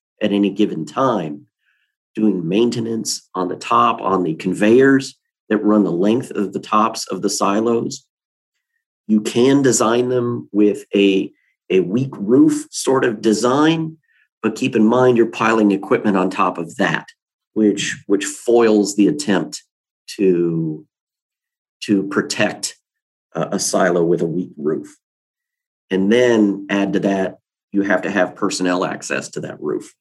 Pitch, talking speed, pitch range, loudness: 110 Hz, 150 wpm, 100-125 Hz, -17 LUFS